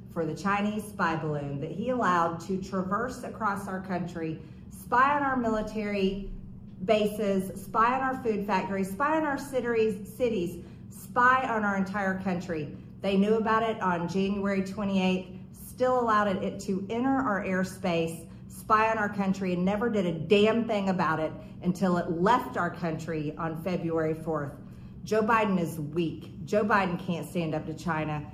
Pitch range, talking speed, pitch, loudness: 170-215 Hz, 165 wpm, 190 Hz, -28 LUFS